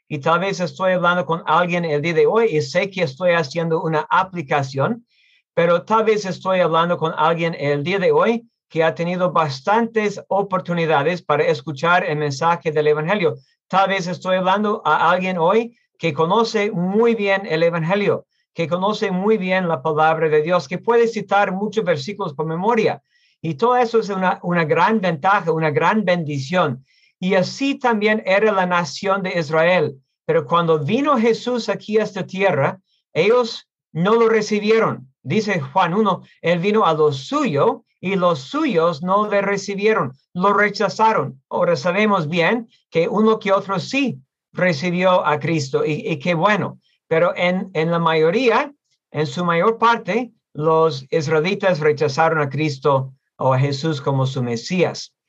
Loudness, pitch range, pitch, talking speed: -19 LUFS, 160-210 Hz, 180 Hz, 165 wpm